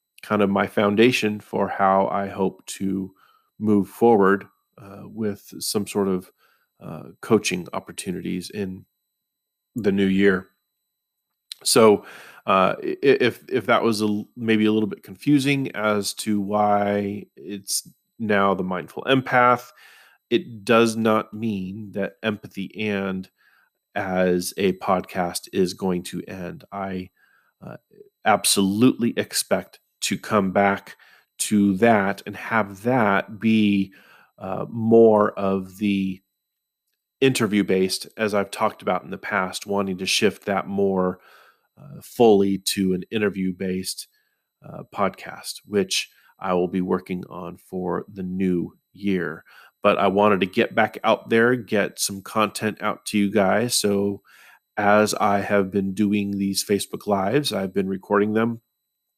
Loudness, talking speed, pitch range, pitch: -22 LUFS, 135 wpm, 95-110 Hz, 100 Hz